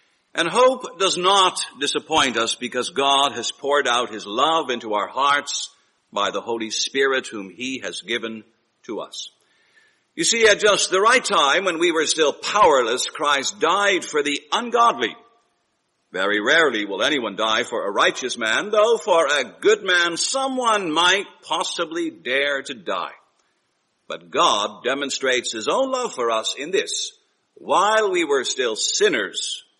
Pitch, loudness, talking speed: 210 Hz, -20 LUFS, 155 wpm